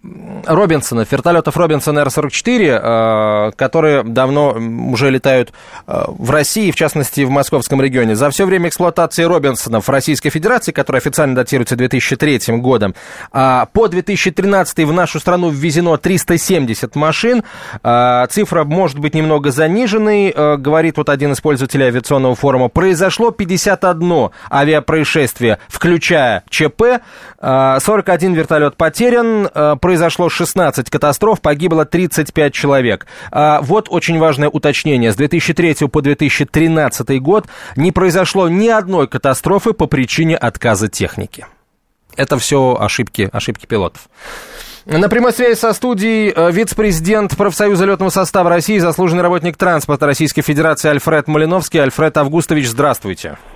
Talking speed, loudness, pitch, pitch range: 120 wpm, -13 LUFS, 155 Hz, 140-180 Hz